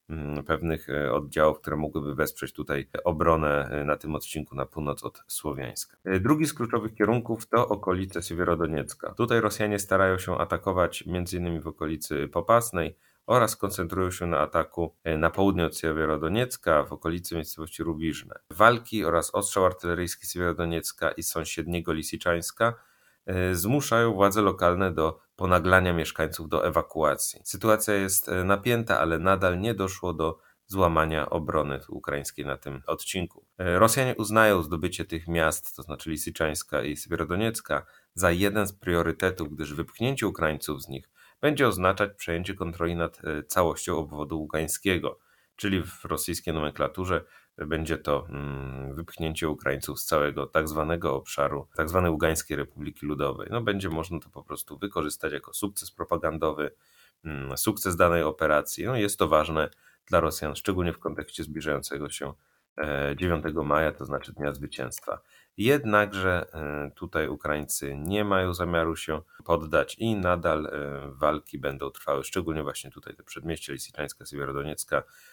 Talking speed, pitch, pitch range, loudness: 135 wpm, 85 Hz, 75-95 Hz, -27 LUFS